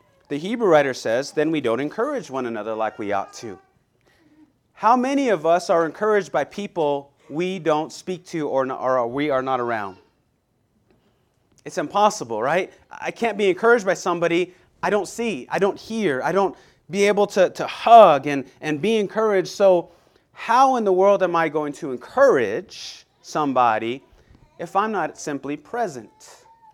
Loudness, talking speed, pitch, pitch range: -21 LUFS, 170 wpm, 180 Hz, 145-210 Hz